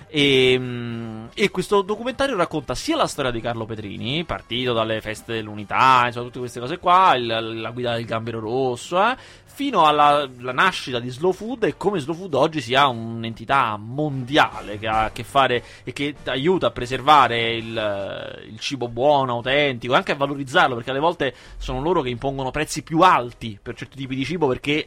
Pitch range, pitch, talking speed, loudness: 115-150 Hz, 130 Hz, 185 wpm, -21 LUFS